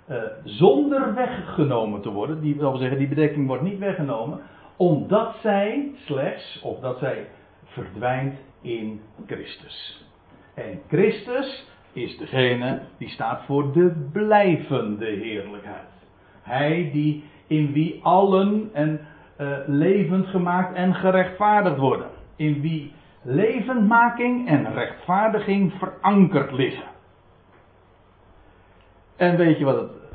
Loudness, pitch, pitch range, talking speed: -22 LUFS, 155 Hz, 125-190 Hz, 115 wpm